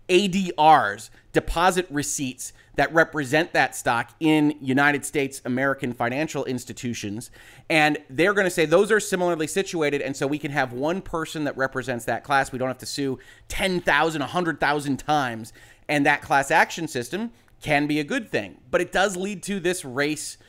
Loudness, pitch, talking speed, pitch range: -23 LUFS, 145 Hz, 170 wpm, 130-160 Hz